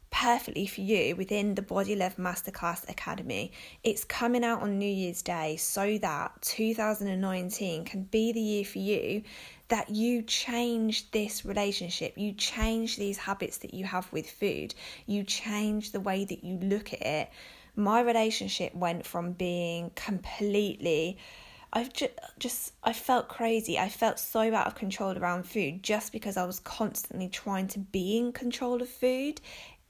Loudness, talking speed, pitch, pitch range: -31 LUFS, 160 wpm, 205 Hz, 190-225 Hz